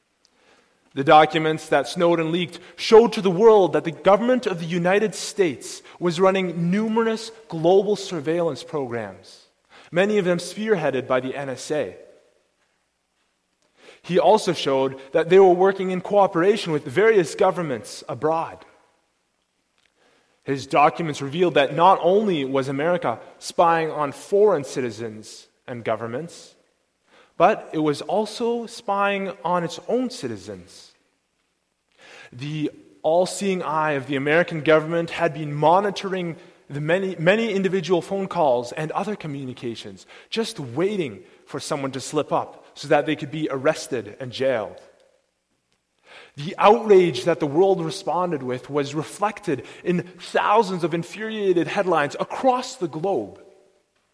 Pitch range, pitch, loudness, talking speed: 150-195 Hz, 175 Hz, -21 LUFS, 130 wpm